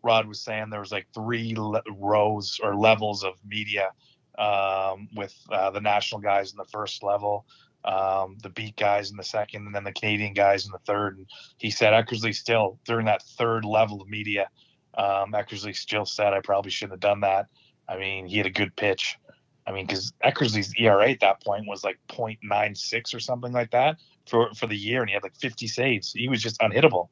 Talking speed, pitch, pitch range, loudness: 210 wpm, 105 Hz, 100-110 Hz, -25 LUFS